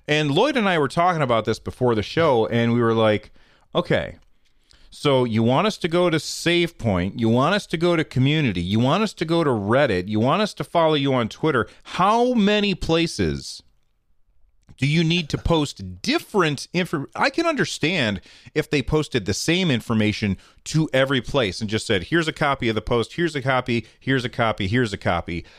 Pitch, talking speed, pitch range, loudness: 135 Hz, 200 wpm, 110-170 Hz, -21 LUFS